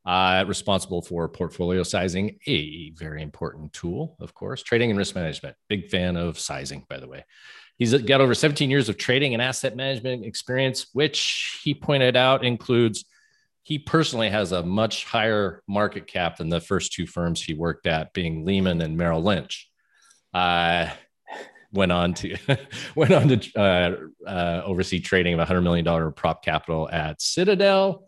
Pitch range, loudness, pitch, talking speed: 85-130 Hz, -23 LUFS, 100 Hz, 165 wpm